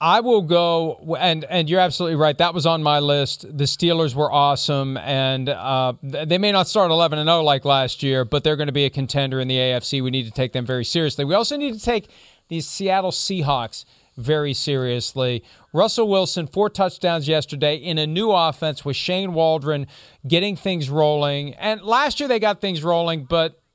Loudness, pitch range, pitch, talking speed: -20 LUFS, 140-175 Hz, 155 Hz, 200 wpm